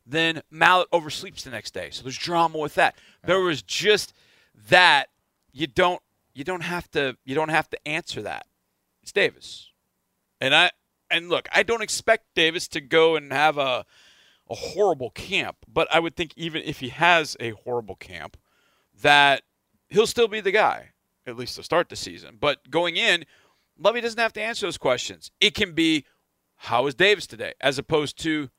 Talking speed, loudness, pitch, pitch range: 185 wpm, -22 LUFS, 160 Hz, 145-180 Hz